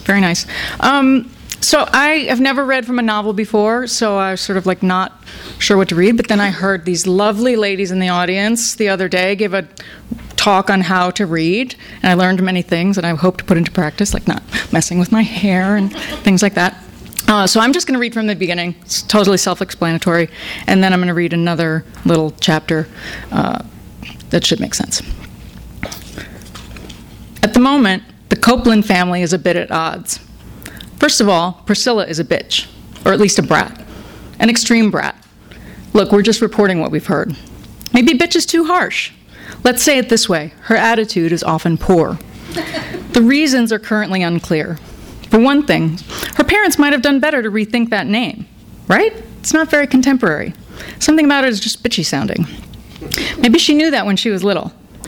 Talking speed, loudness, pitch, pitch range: 195 wpm, -14 LUFS, 205 Hz, 180-240 Hz